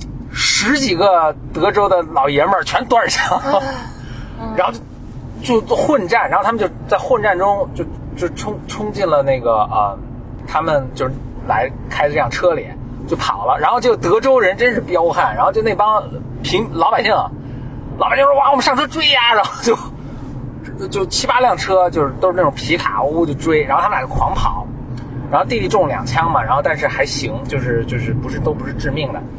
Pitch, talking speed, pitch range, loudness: 155 Hz, 275 characters per minute, 130-210 Hz, -16 LUFS